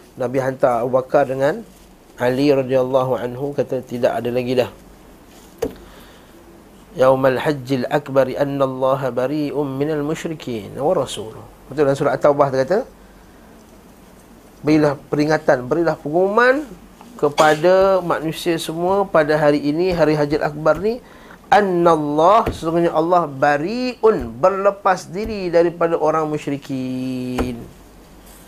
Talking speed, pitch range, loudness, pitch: 105 wpm, 135-175 Hz, -18 LUFS, 150 Hz